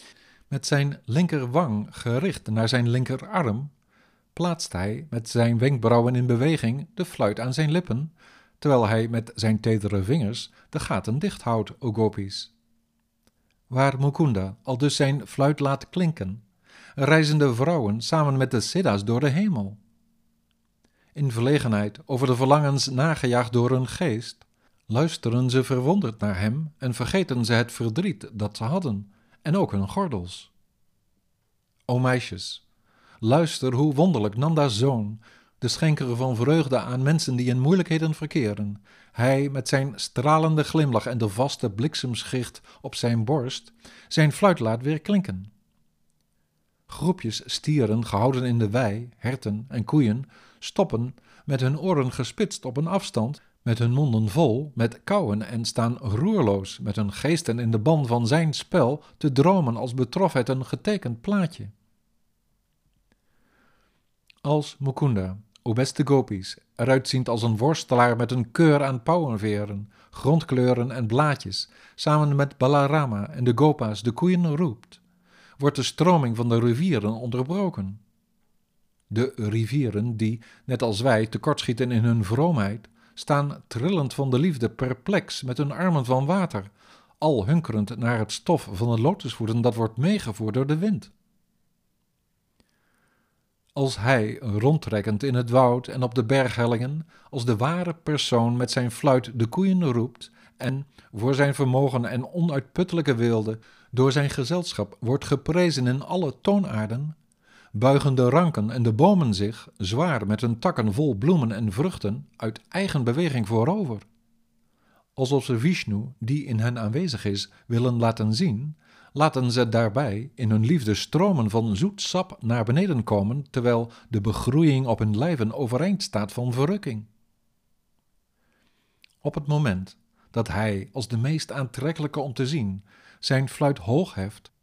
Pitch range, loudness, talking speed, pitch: 110-150 Hz, -24 LUFS, 145 wpm, 125 Hz